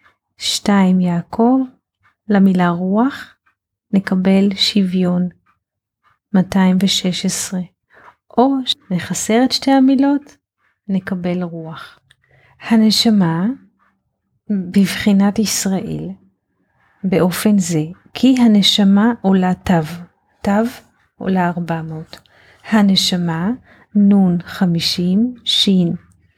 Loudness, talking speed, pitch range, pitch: -15 LUFS, 70 wpm, 175-215 Hz, 190 Hz